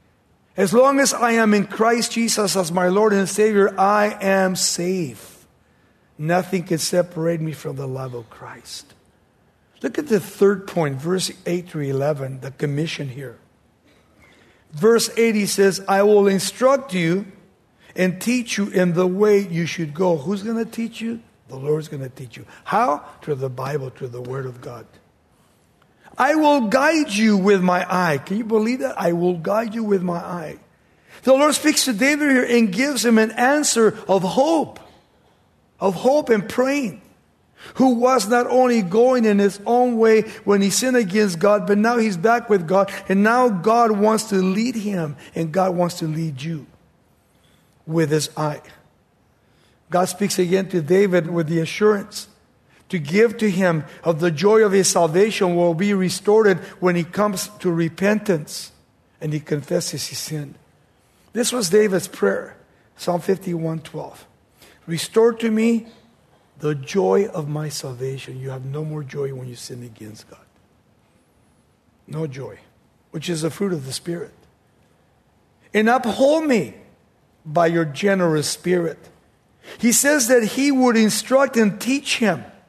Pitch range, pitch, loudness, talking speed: 160-220 Hz, 190 Hz, -19 LUFS, 165 wpm